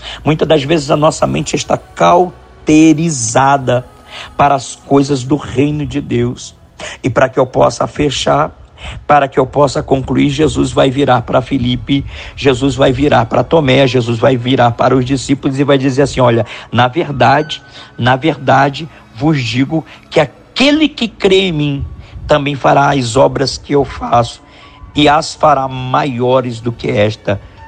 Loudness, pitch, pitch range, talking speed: -12 LUFS, 140 Hz, 125-145 Hz, 160 wpm